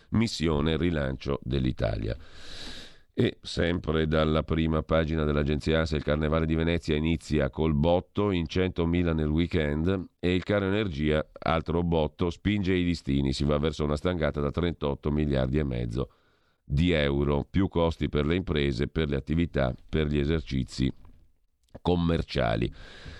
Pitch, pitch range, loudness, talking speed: 80 Hz, 75-85 Hz, -28 LUFS, 140 wpm